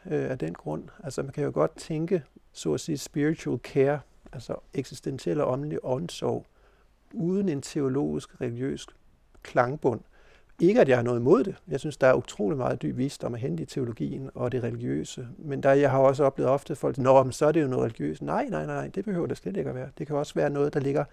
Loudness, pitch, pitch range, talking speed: -27 LUFS, 135 Hz, 130-150 Hz, 230 wpm